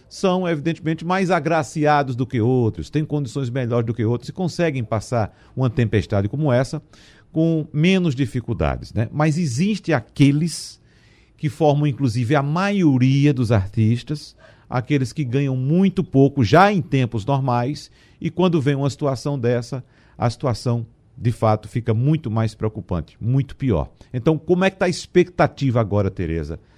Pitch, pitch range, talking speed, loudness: 135 Hz, 115-155 Hz, 150 wpm, -20 LUFS